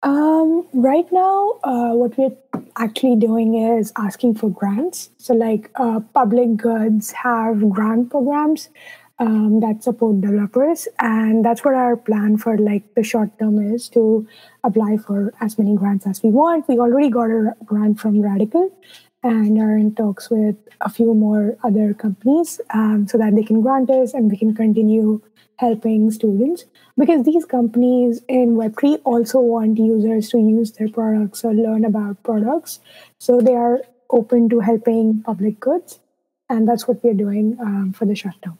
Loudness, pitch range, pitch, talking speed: -17 LUFS, 215-250 Hz, 230 Hz, 170 wpm